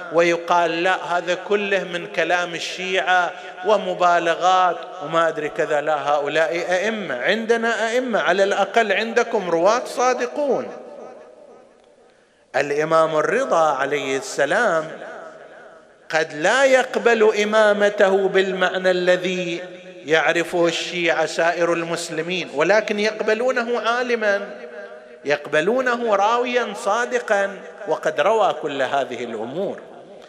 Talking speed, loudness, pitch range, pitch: 90 wpm, -20 LUFS, 165-215 Hz, 180 Hz